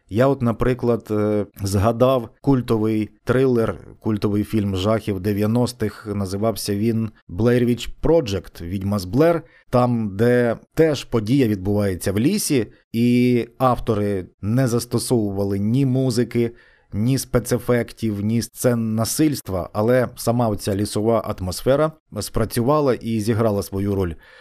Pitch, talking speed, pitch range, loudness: 115 Hz, 110 wpm, 105-125 Hz, -21 LUFS